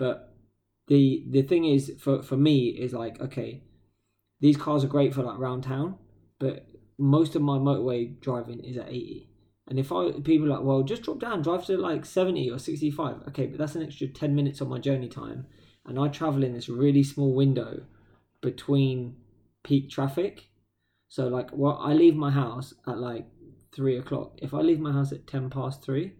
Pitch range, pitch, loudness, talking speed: 120-145 Hz, 135 Hz, -27 LUFS, 200 wpm